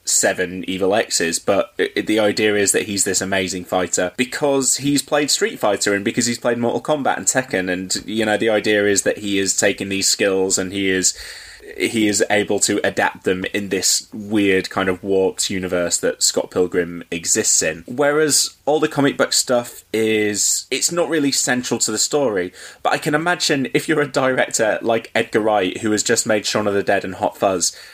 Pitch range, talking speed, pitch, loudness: 95-130 Hz, 205 wpm, 105 Hz, -18 LUFS